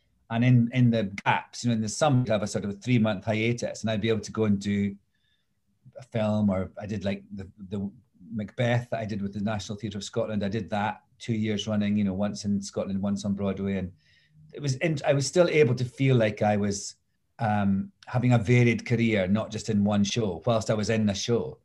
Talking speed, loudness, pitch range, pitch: 245 wpm, -27 LUFS, 100-120 Hz, 110 Hz